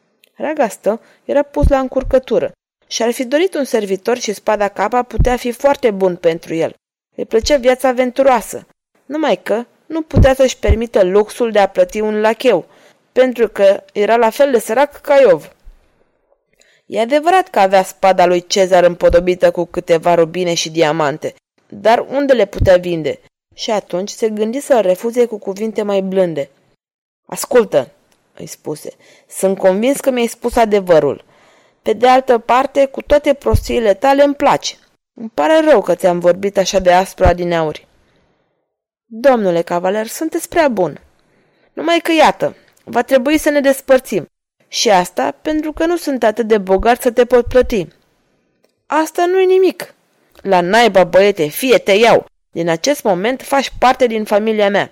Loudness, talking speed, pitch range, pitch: -14 LUFS, 160 wpm, 190-275 Hz, 230 Hz